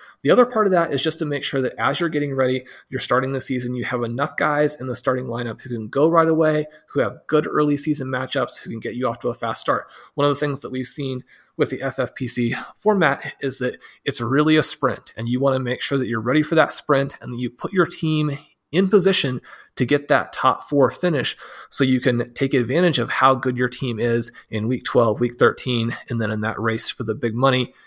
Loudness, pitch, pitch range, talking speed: -21 LUFS, 130 Hz, 125-150 Hz, 250 wpm